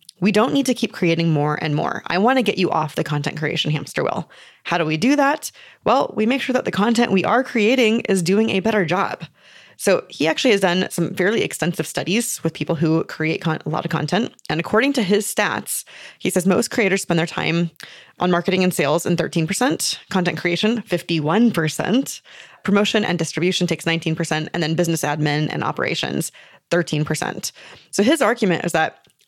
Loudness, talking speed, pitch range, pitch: -20 LUFS, 195 wpm, 165-215 Hz, 180 Hz